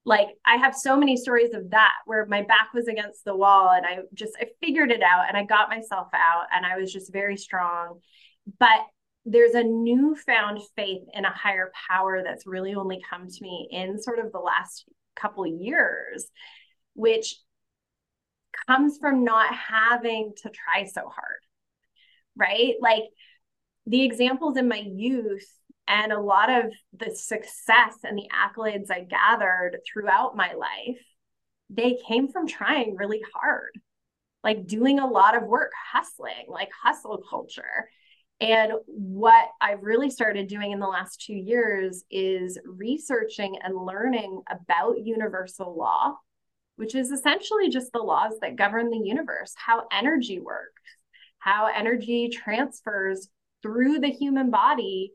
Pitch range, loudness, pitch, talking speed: 200-250 Hz, -23 LUFS, 220 Hz, 150 wpm